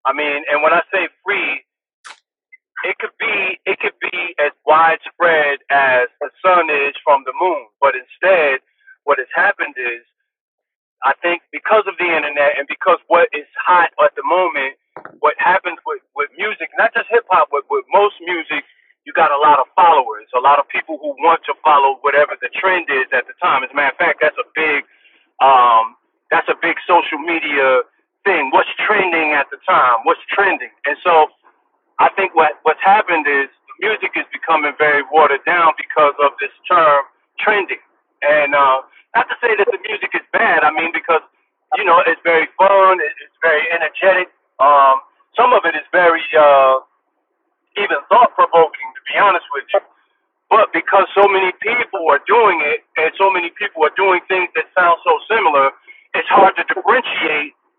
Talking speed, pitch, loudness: 185 wpm, 175 Hz, -14 LUFS